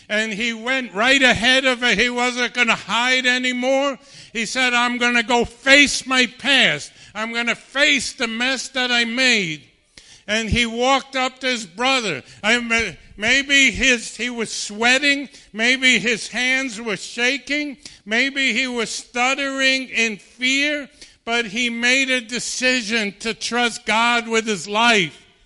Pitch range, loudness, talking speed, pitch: 225-260 Hz, -18 LUFS, 155 wpm, 240 Hz